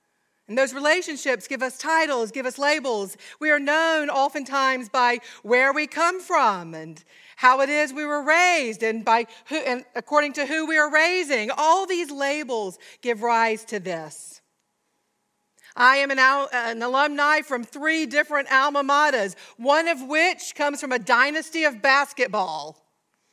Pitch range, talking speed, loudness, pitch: 245-300 Hz, 155 wpm, -21 LUFS, 275 Hz